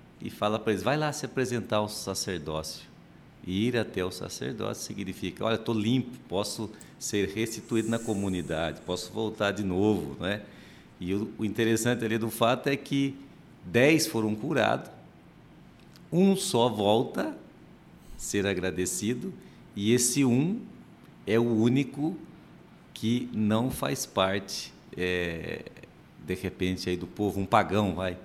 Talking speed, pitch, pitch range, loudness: 140 wpm, 110 Hz, 95-125 Hz, -29 LUFS